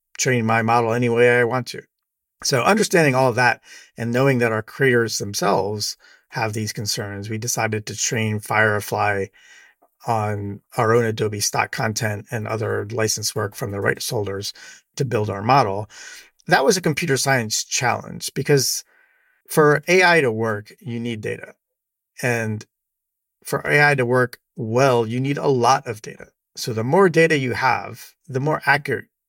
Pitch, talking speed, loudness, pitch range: 120 Hz, 165 wpm, -20 LUFS, 110-135 Hz